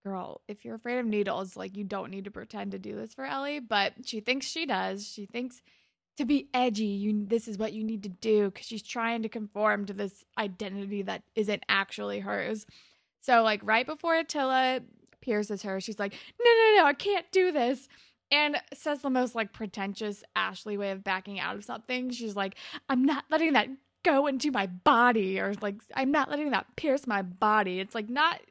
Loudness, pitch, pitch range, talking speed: -29 LUFS, 225 Hz, 205-270 Hz, 205 wpm